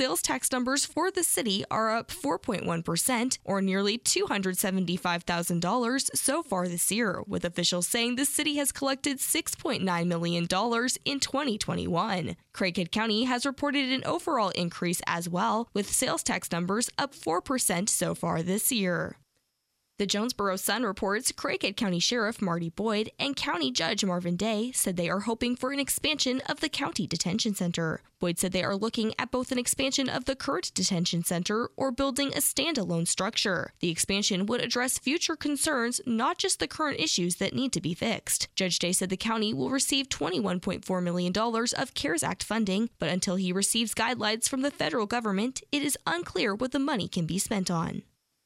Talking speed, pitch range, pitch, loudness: 170 wpm, 185-260 Hz, 220 Hz, -28 LUFS